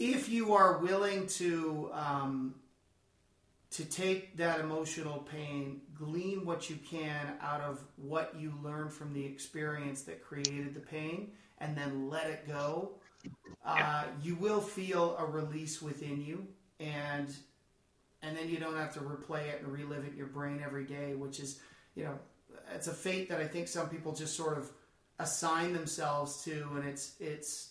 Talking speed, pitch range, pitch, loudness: 170 wpm, 145-165 Hz, 150 Hz, -37 LUFS